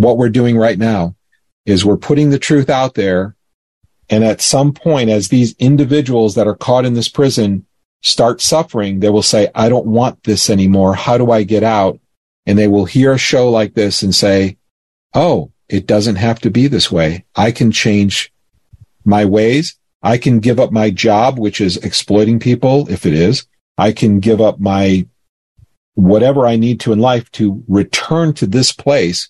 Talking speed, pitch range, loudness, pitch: 190 wpm, 100-125 Hz, -12 LUFS, 110 Hz